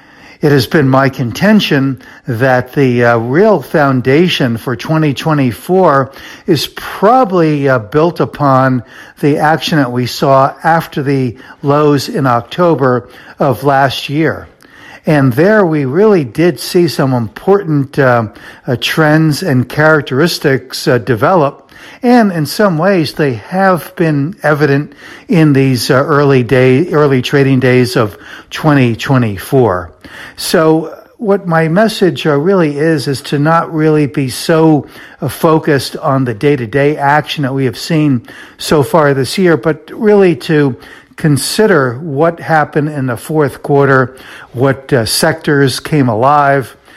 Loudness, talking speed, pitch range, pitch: -11 LUFS, 135 wpm, 130-160 Hz, 145 Hz